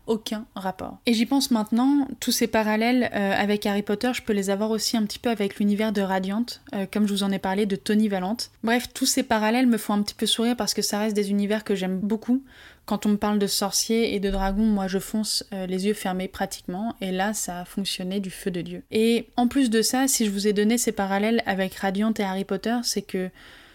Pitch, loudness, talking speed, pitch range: 210 Hz, -24 LUFS, 250 wpm, 195-230 Hz